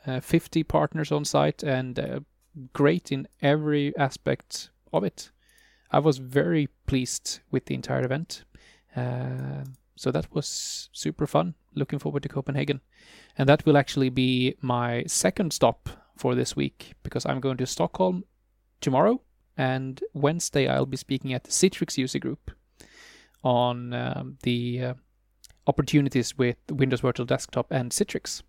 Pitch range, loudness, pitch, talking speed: 120-150 Hz, -26 LUFS, 135 Hz, 145 wpm